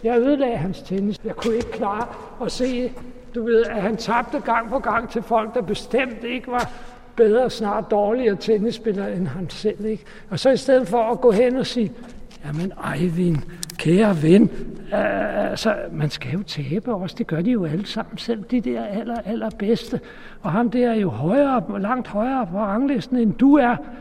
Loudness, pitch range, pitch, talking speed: -21 LUFS, 200-240 Hz, 230 Hz, 195 wpm